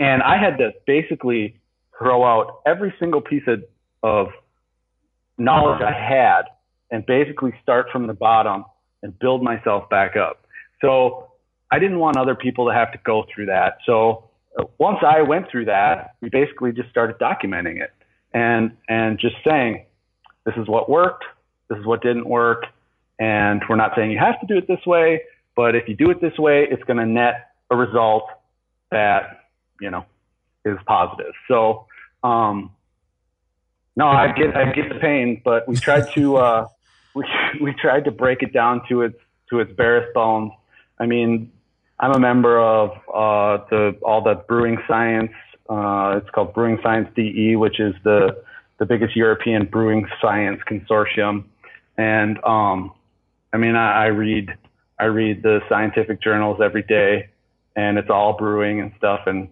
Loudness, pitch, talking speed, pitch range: -19 LUFS, 115 Hz, 170 wpm, 105-125 Hz